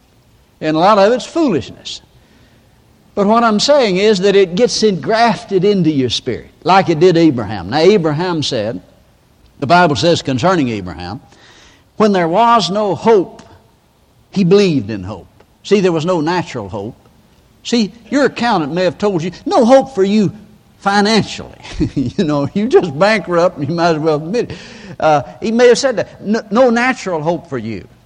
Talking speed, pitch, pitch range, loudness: 170 wpm, 185 Hz, 155-215 Hz, -13 LUFS